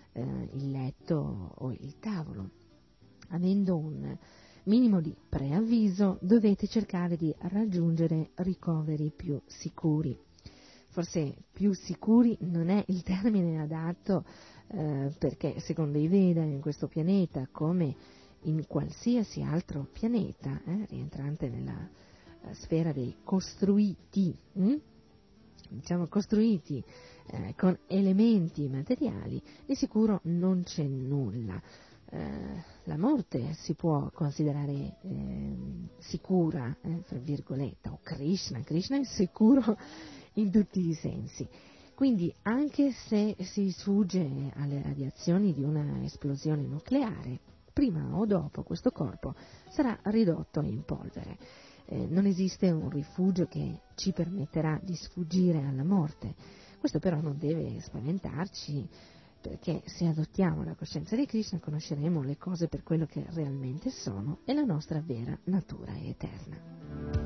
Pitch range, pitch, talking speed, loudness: 145-195 Hz, 165 Hz, 120 wpm, -31 LUFS